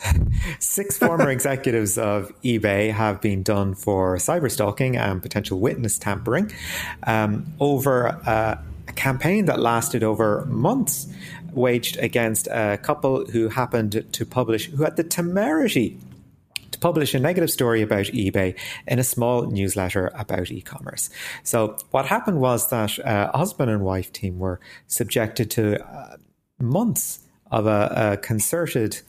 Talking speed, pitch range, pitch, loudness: 145 wpm, 105-130 Hz, 115 Hz, -22 LUFS